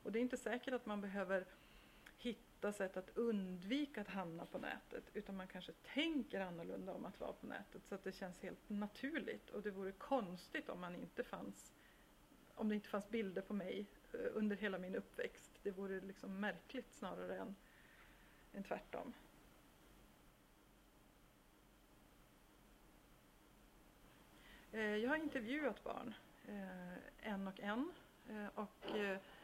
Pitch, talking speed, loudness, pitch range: 210 Hz, 145 wpm, -47 LUFS, 195-240 Hz